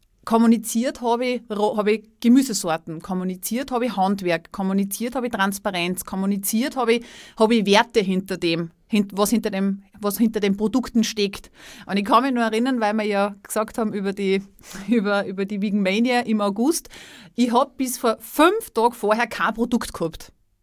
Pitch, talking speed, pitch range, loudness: 215 Hz, 170 wpm, 195-235 Hz, -22 LUFS